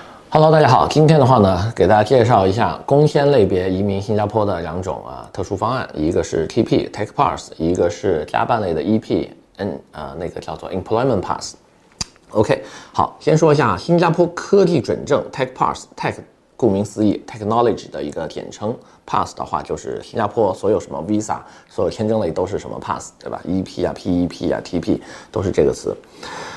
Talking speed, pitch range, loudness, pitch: 385 characters per minute, 100-165 Hz, -18 LUFS, 130 Hz